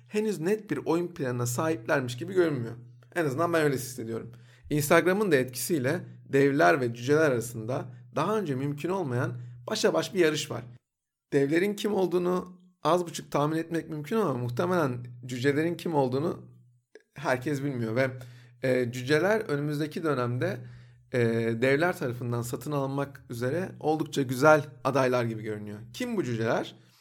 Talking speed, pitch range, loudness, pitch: 135 wpm, 120-160 Hz, -28 LUFS, 140 Hz